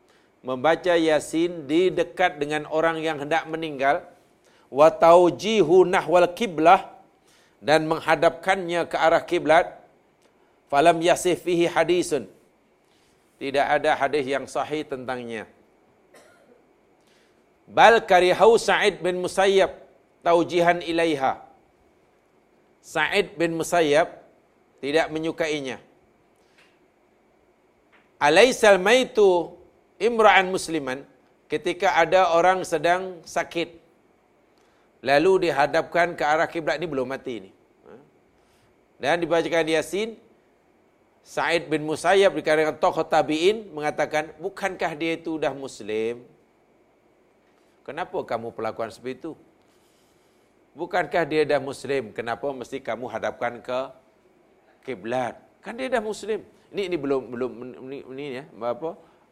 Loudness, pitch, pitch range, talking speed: -22 LUFS, 160 Hz, 140-175 Hz, 100 wpm